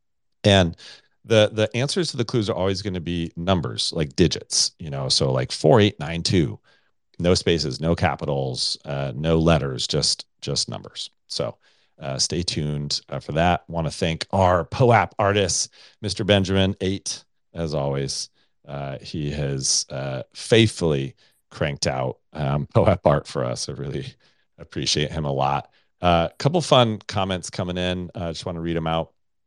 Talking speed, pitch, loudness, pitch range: 165 wpm, 85 Hz, -22 LUFS, 70-95 Hz